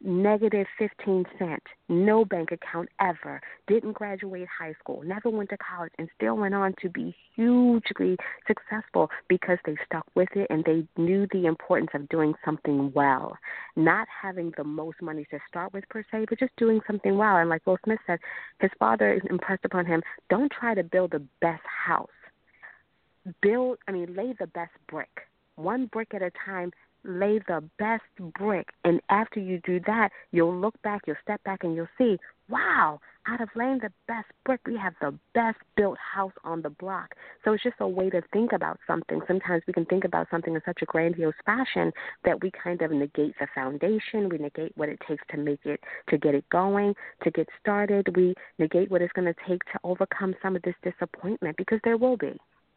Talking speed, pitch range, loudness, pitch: 200 wpm, 165-210 Hz, -27 LUFS, 185 Hz